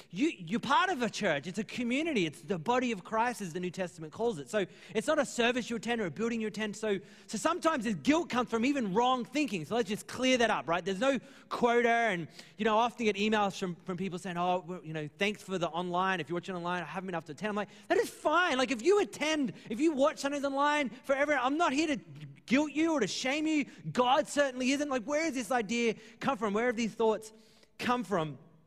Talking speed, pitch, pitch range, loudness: 255 wpm, 225 Hz, 190-270 Hz, -31 LUFS